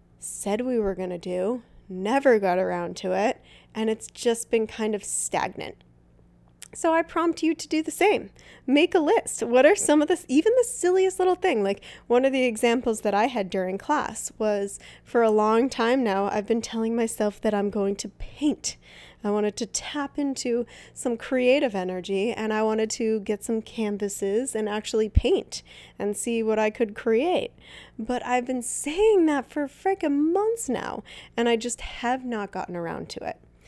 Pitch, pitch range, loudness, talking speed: 230 Hz, 210-275 Hz, -25 LUFS, 190 wpm